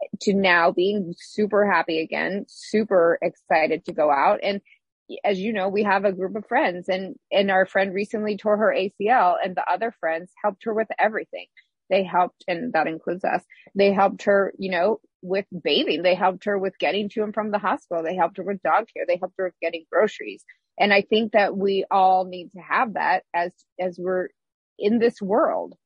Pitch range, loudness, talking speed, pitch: 180-210 Hz, -23 LUFS, 205 wpm, 195 Hz